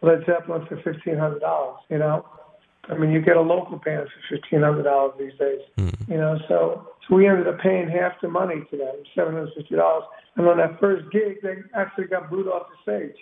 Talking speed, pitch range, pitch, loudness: 195 wpm, 150-185 Hz, 165 Hz, -23 LUFS